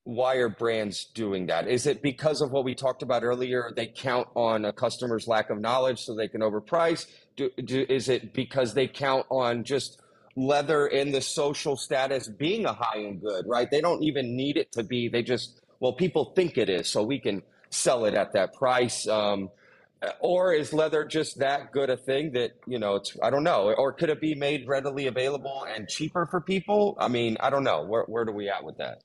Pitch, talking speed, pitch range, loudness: 130 Hz, 220 wpm, 115-145 Hz, -27 LUFS